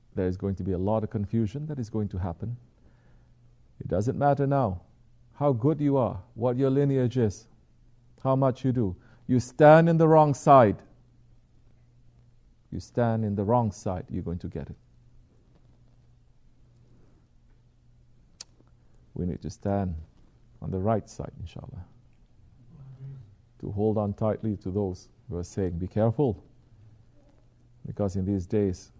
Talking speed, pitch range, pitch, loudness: 145 wpm, 100-125 Hz, 120 Hz, -26 LUFS